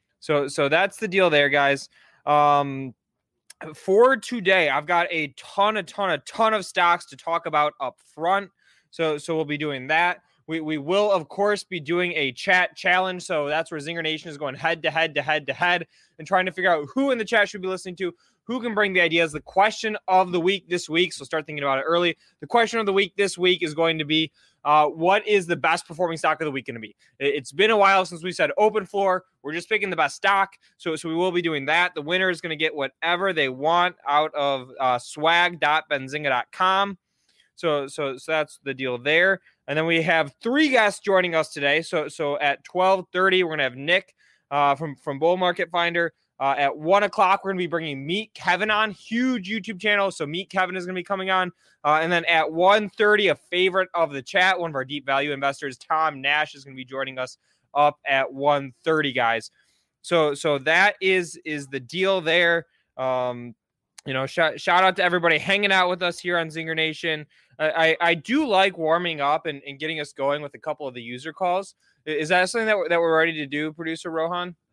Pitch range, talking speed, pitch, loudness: 150-185 Hz, 225 wpm, 165 Hz, -22 LUFS